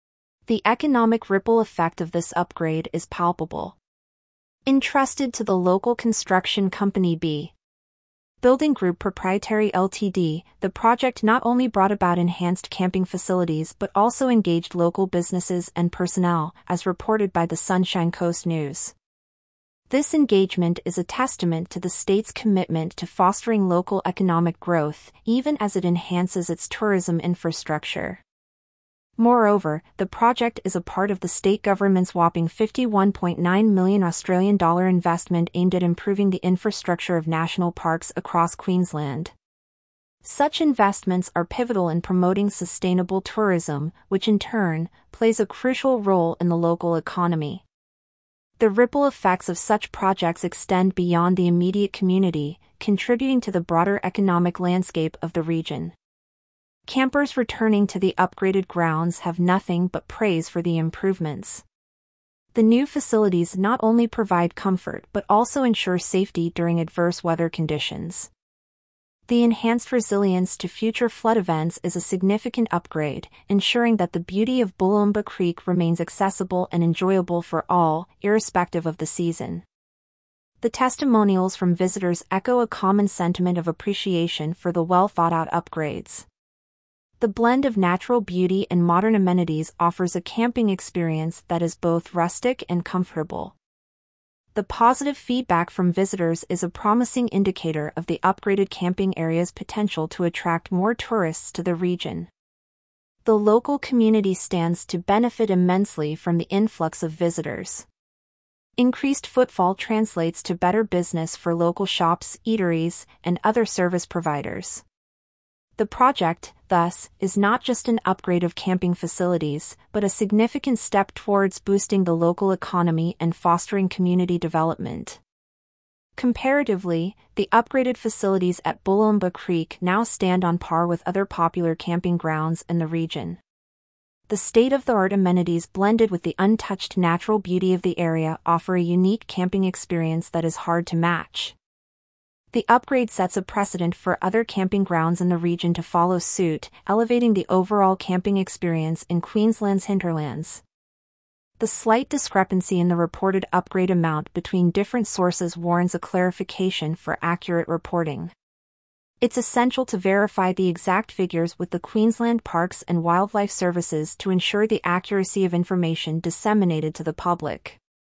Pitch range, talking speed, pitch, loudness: 170-205 Hz, 140 wpm, 185 Hz, -22 LUFS